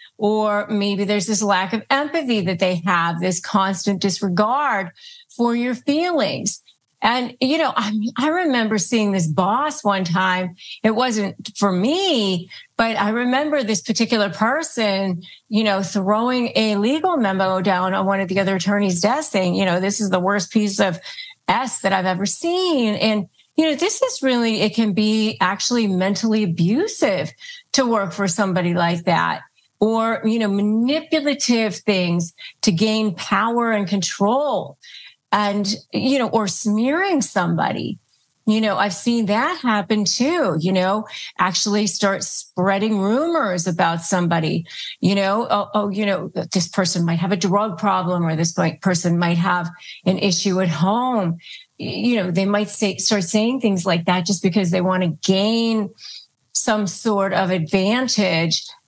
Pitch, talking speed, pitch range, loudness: 205 Hz, 160 wpm, 190-230 Hz, -19 LUFS